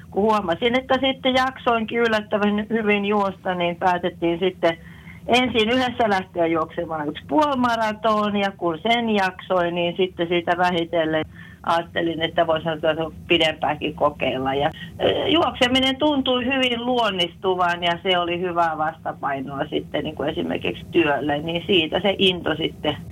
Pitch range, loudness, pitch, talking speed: 170-230 Hz, -21 LUFS, 185 Hz, 130 wpm